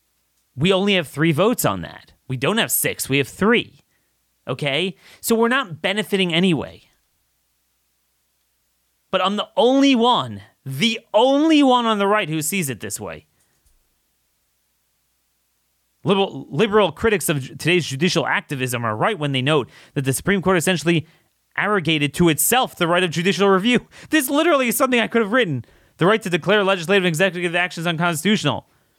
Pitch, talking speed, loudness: 170 Hz, 160 wpm, -19 LUFS